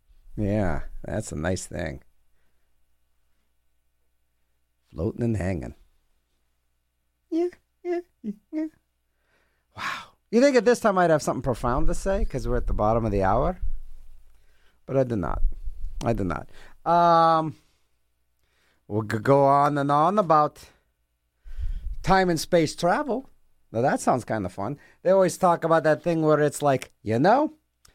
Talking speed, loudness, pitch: 140 wpm, -24 LUFS, 100 Hz